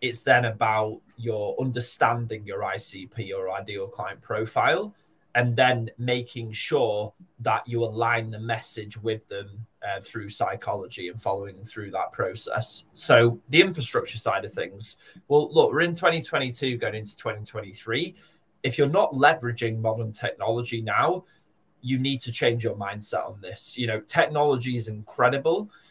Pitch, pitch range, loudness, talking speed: 115 Hz, 110-130 Hz, -25 LUFS, 150 wpm